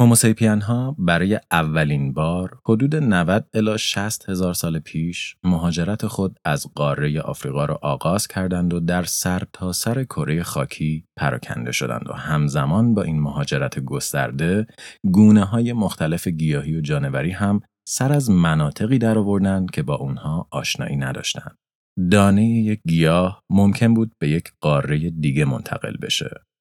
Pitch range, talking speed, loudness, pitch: 80-110 Hz, 140 wpm, -20 LUFS, 90 Hz